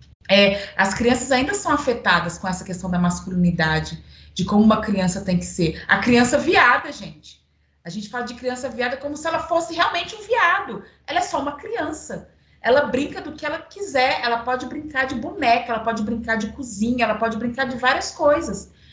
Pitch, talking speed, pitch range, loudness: 245 Hz, 195 wpm, 195-290 Hz, -21 LUFS